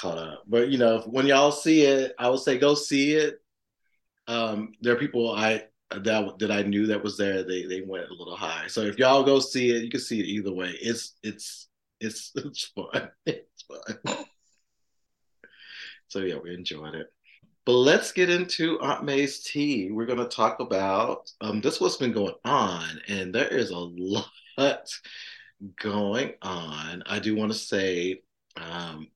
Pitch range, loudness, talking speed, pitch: 95-130 Hz, -26 LUFS, 180 wpm, 110 Hz